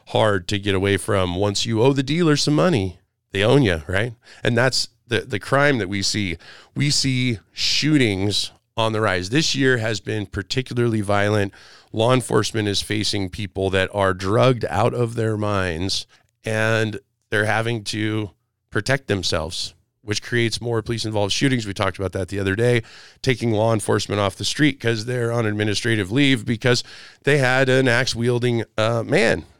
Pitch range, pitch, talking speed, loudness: 100-120 Hz, 110 Hz, 175 wpm, -21 LUFS